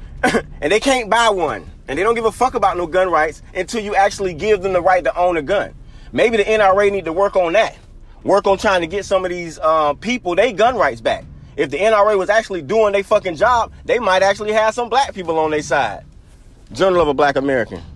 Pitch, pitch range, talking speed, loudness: 190 Hz, 160-215 Hz, 240 wpm, -17 LUFS